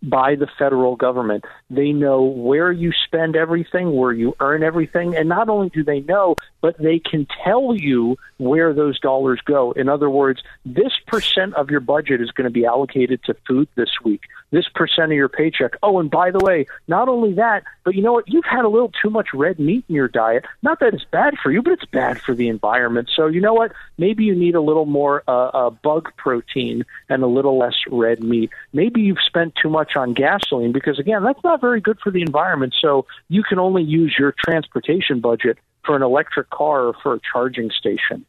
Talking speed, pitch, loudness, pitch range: 220 wpm, 150 Hz, -18 LUFS, 130-180 Hz